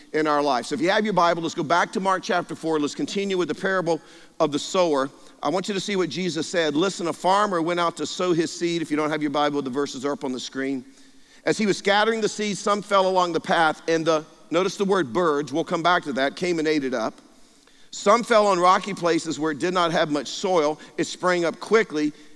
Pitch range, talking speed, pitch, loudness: 155-195 Hz, 260 wpm, 170 Hz, -23 LUFS